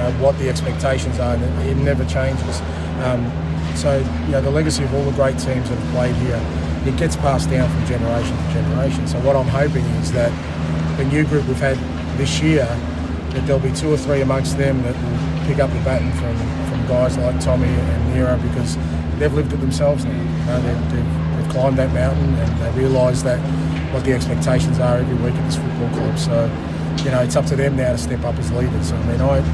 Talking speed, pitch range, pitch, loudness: 225 wpm, 80-125 Hz, 80 Hz, -19 LUFS